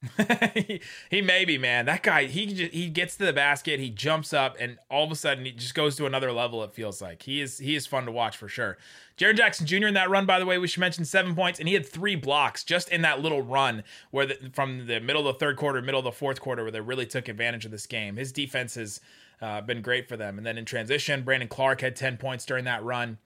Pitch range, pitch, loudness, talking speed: 120-160 Hz, 135 Hz, -26 LUFS, 270 wpm